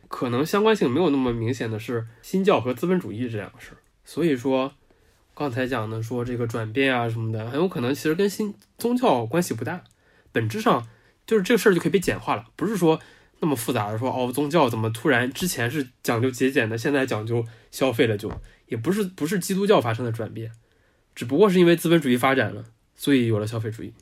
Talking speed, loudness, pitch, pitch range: 340 characters per minute, -23 LUFS, 130 Hz, 115-165 Hz